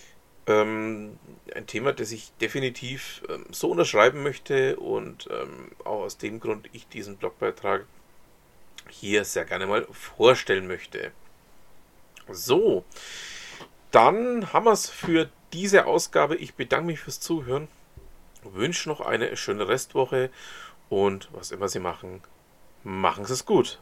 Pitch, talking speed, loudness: 165 Hz, 125 wpm, -25 LUFS